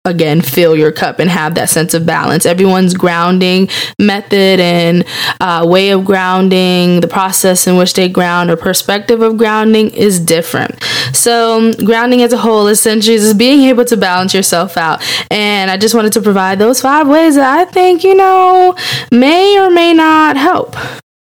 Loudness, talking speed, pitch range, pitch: -9 LUFS, 175 wpm, 180-235 Hz, 195 Hz